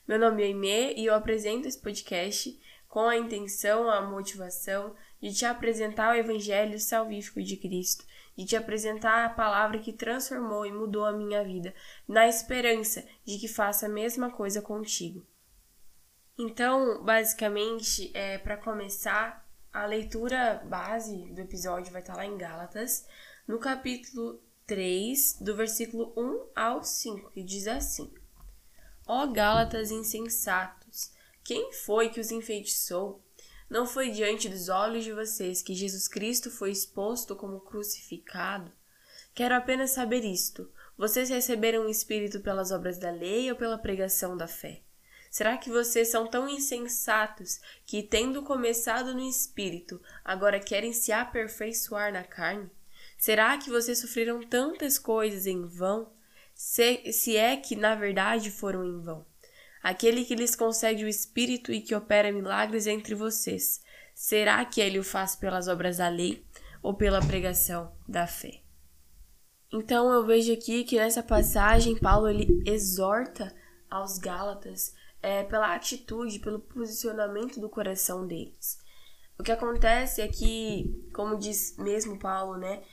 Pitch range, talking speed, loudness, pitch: 195-230 Hz, 145 wpm, -29 LUFS, 215 Hz